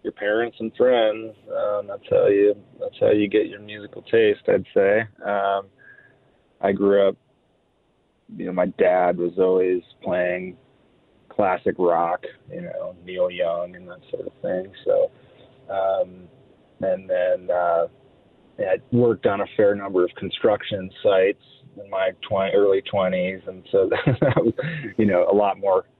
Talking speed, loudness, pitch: 145 wpm, -22 LUFS, 105 Hz